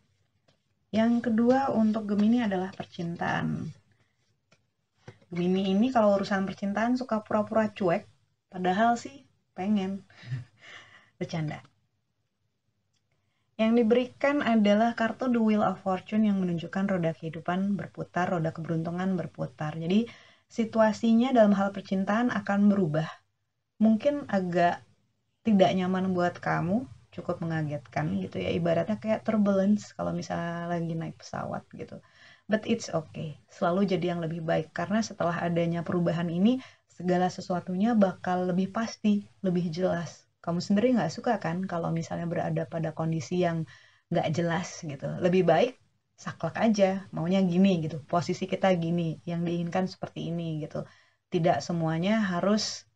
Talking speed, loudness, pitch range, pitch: 125 wpm, -28 LUFS, 165-205 Hz, 180 Hz